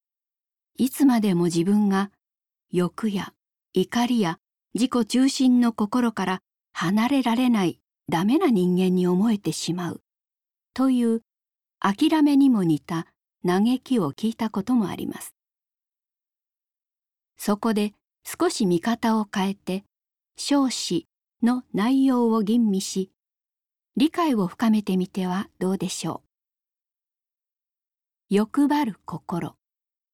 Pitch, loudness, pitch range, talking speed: 215 Hz, -23 LUFS, 185-245 Hz, 200 characters per minute